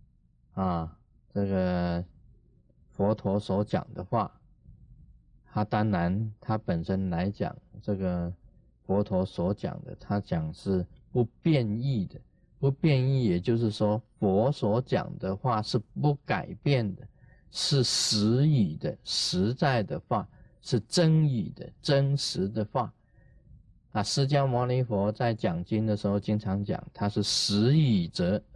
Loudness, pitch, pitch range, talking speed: -28 LUFS, 105 Hz, 95-130 Hz, 175 characters per minute